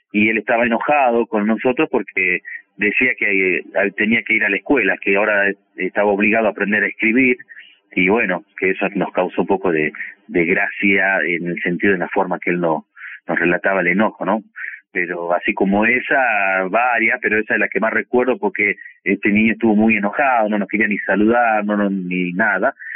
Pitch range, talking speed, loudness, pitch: 95-110 Hz, 195 wpm, -17 LUFS, 105 Hz